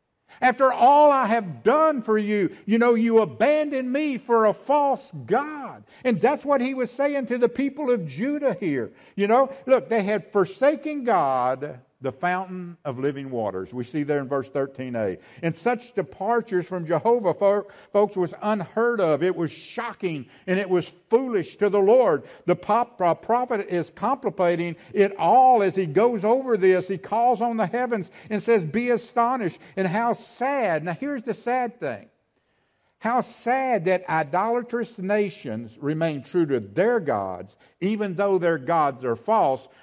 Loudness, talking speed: -23 LUFS, 165 wpm